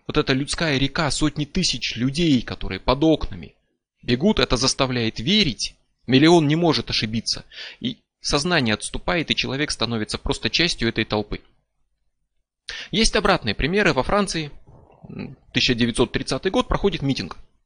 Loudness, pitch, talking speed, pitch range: -21 LUFS, 135 Hz, 125 wpm, 115-165 Hz